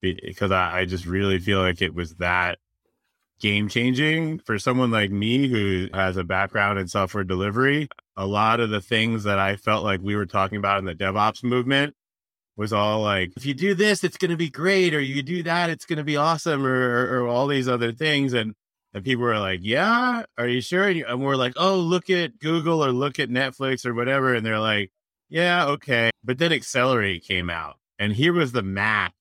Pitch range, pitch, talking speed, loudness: 100-145 Hz, 120 Hz, 220 wpm, -23 LUFS